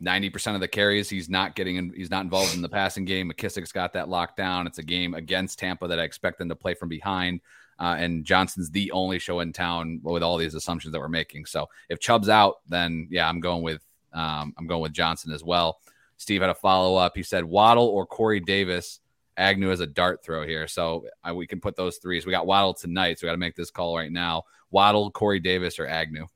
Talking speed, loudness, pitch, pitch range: 245 wpm, -25 LUFS, 90 Hz, 85-95 Hz